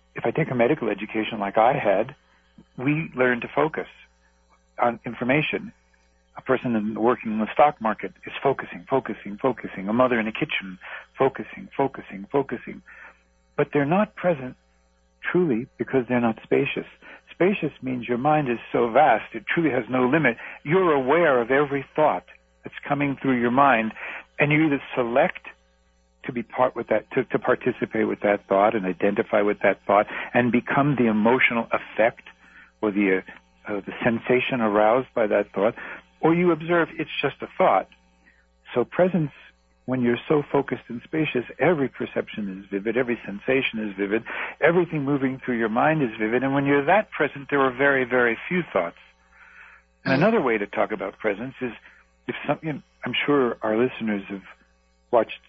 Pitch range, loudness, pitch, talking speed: 100-140 Hz, -23 LUFS, 120 Hz, 170 wpm